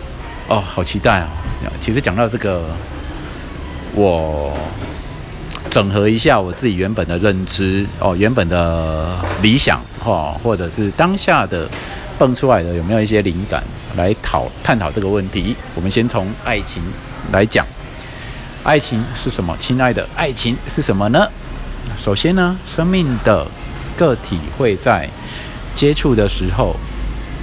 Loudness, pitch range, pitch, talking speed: -17 LUFS, 85-120 Hz, 100 Hz, 205 characters per minute